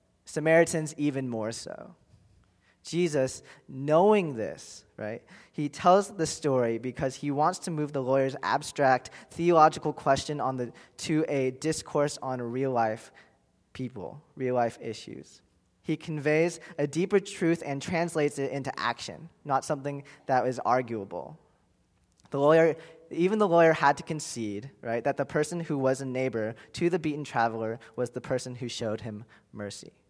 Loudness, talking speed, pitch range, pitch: -28 LUFS, 150 wpm, 120-160 Hz, 140 Hz